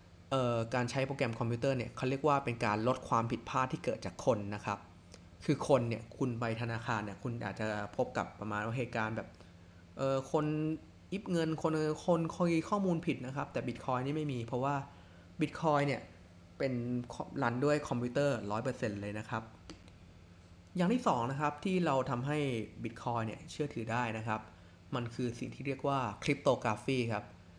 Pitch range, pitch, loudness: 105-140 Hz, 120 Hz, -35 LUFS